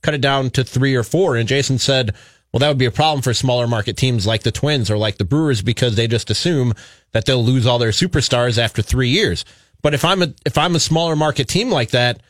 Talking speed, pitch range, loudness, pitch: 255 wpm, 115-145 Hz, -17 LUFS, 125 Hz